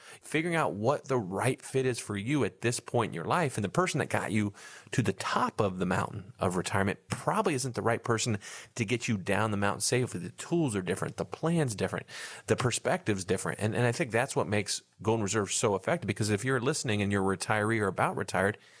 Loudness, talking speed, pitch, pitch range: -30 LUFS, 235 wpm, 110 Hz, 100-130 Hz